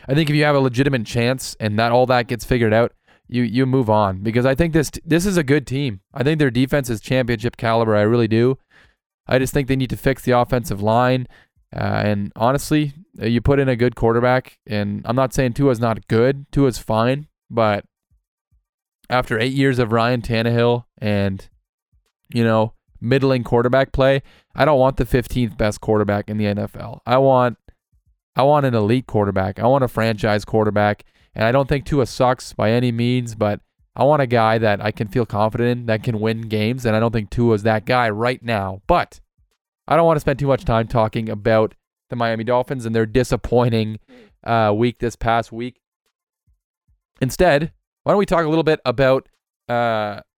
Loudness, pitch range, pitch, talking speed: -19 LUFS, 110-130 Hz, 120 Hz, 200 wpm